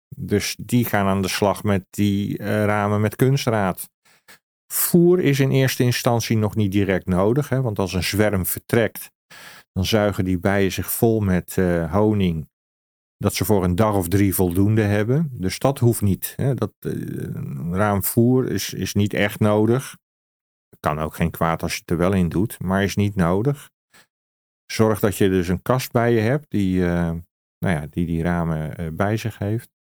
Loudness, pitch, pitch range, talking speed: -21 LUFS, 100 Hz, 90-110 Hz, 185 wpm